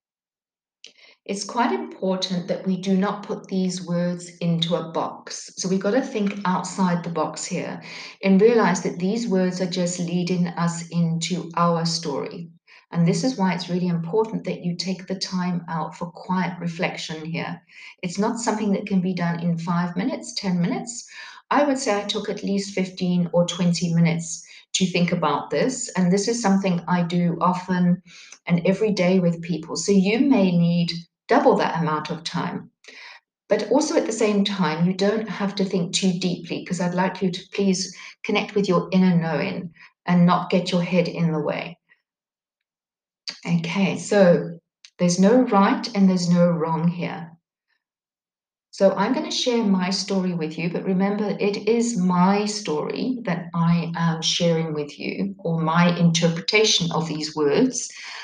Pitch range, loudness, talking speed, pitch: 170-200 Hz, -22 LUFS, 175 wpm, 180 Hz